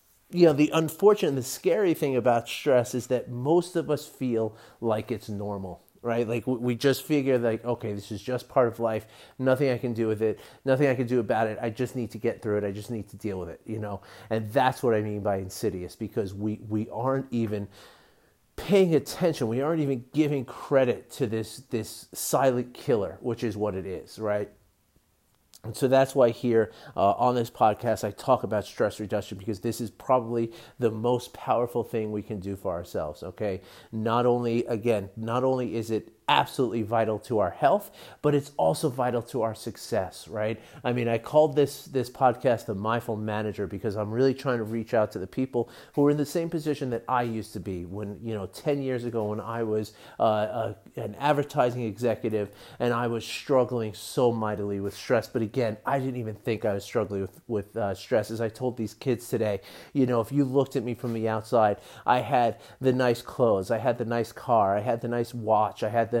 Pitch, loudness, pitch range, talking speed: 115 Hz, -27 LUFS, 110-130 Hz, 215 wpm